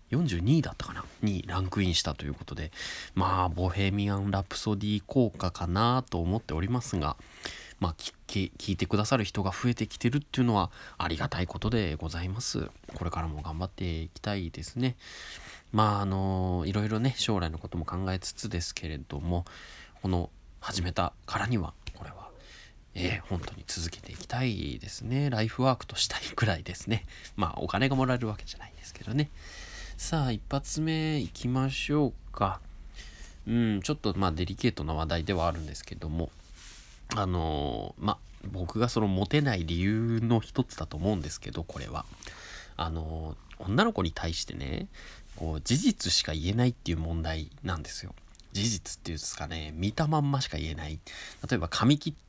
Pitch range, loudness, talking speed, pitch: 80-115 Hz, -31 LUFS, 360 characters per minute, 95 Hz